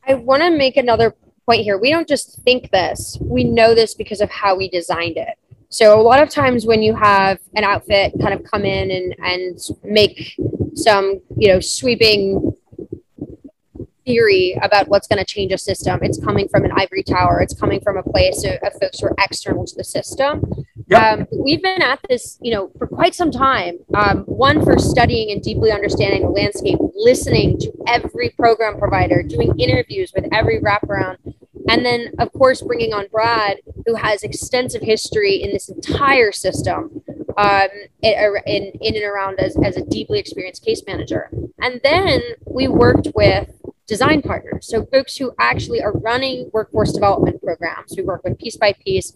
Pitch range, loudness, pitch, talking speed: 200-295 Hz, -16 LUFS, 230 Hz, 180 wpm